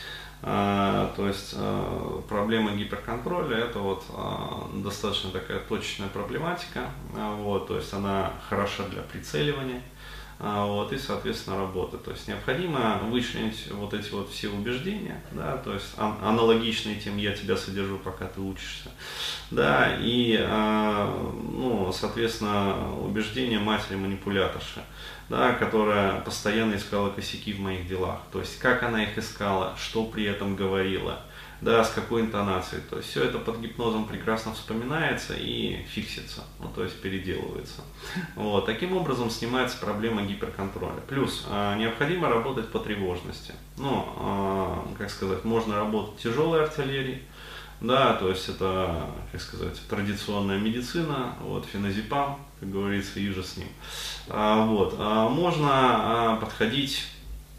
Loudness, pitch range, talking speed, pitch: -28 LUFS, 95-115 Hz, 130 wpm, 105 Hz